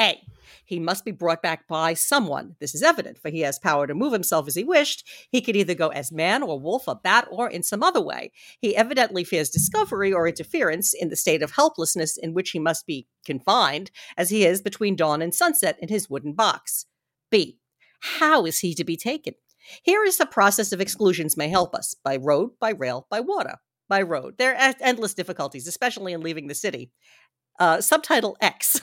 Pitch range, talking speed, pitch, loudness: 160-235 Hz, 210 wpm, 185 Hz, -23 LUFS